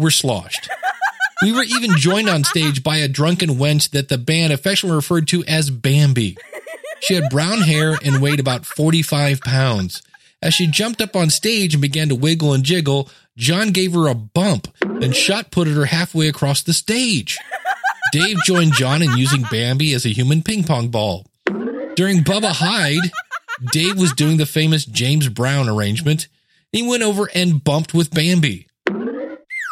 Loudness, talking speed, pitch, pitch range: -17 LUFS, 170 wpm, 155 Hz, 140-185 Hz